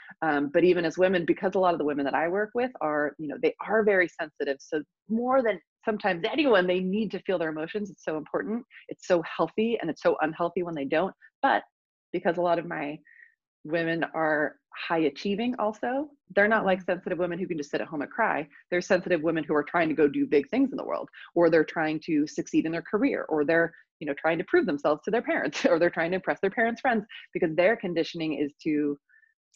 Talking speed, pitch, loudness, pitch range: 235 wpm, 175 Hz, -27 LUFS, 155-215 Hz